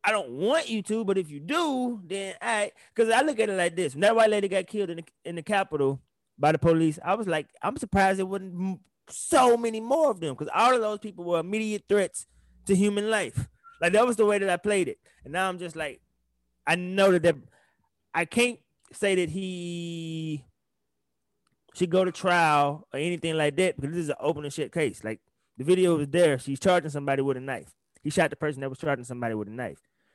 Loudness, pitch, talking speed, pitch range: -26 LUFS, 180 Hz, 230 wpm, 150-205 Hz